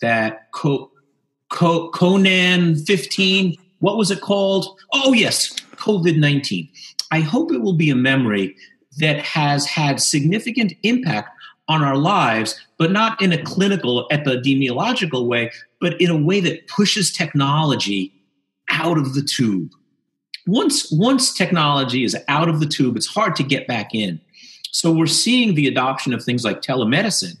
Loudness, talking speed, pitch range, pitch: -18 LUFS, 150 wpm, 135-190 Hz, 160 Hz